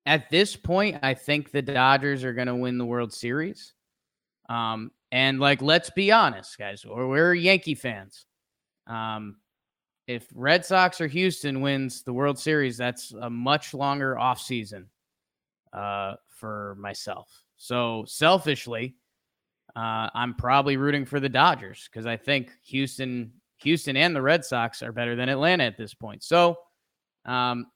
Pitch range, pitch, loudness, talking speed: 115-145 Hz, 130 Hz, -24 LUFS, 155 wpm